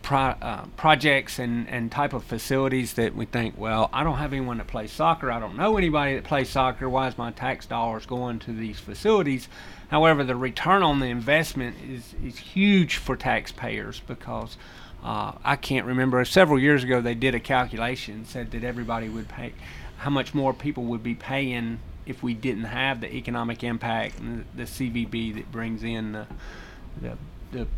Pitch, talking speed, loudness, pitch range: 125 Hz, 185 wpm, -25 LUFS, 115-135 Hz